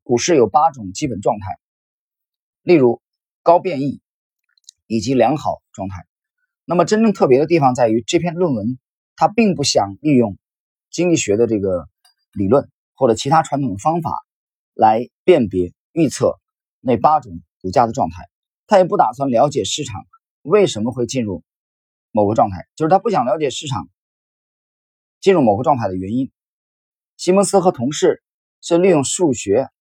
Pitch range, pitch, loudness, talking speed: 110-175 Hz, 140 Hz, -17 LUFS, 240 characters per minute